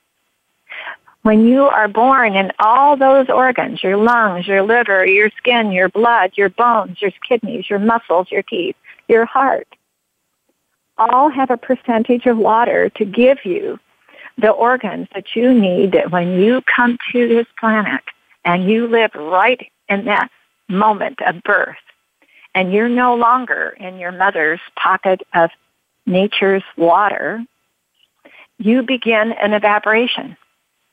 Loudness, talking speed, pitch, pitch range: -14 LUFS, 140 wpm, 220 Hz, 195-245 Hz